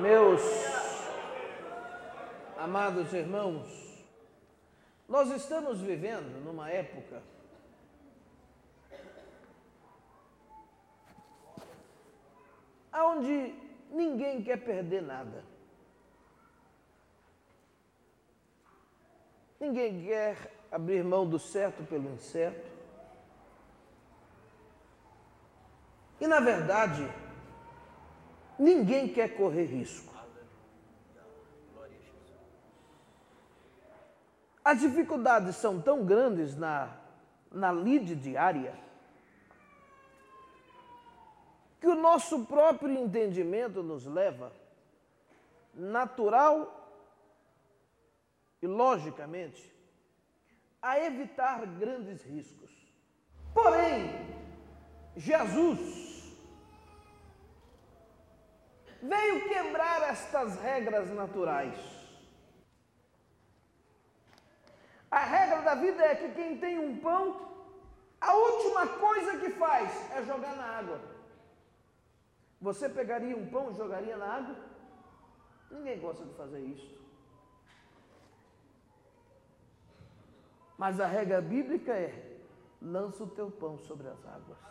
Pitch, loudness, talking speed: 230 Hz, -31 LUFS, 70 wpm